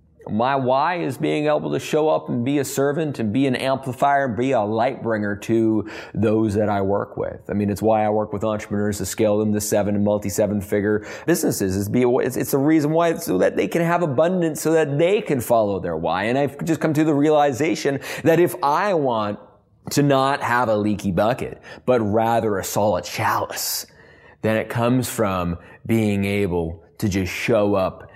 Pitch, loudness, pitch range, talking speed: 110 Hz, -21 LUFS, 105-140 Hz, 200 wpm